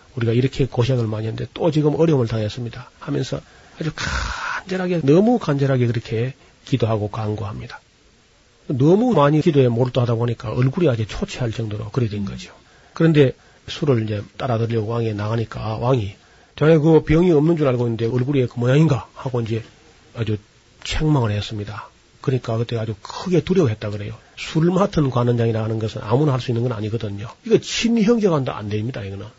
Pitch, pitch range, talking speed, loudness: 120 Hz, 110-150 Hz, 400 characters per minute, -20 LUFS